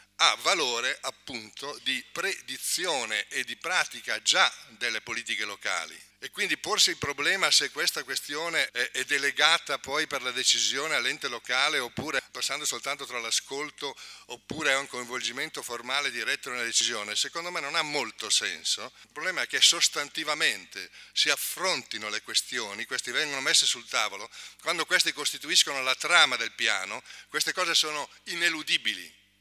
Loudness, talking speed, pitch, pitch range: -26 LUFS, 145 wpm, 145 Hz, 125-165 Hz